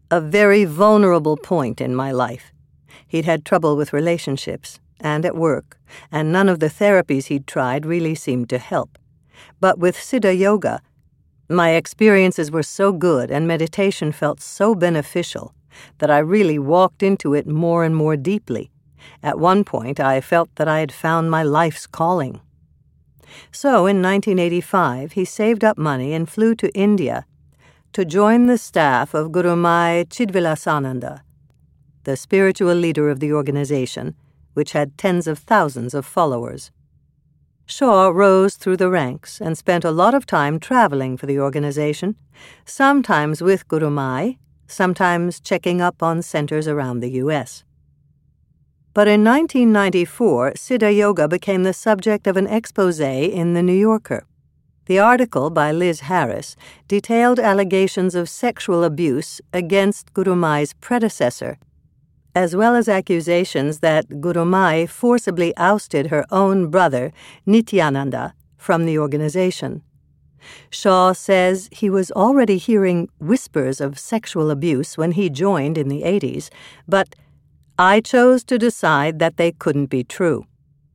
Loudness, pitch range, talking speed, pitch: -18 LUFS, 150-195 Hz, 140 wpm, 175 Hz